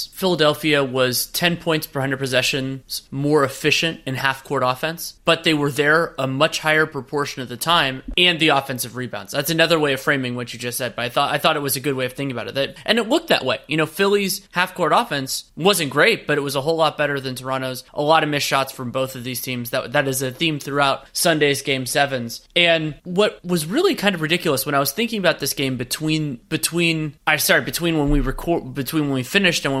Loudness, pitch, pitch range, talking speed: -20 LUFS, 145 Hz, 135-165 Hz, 245 wpm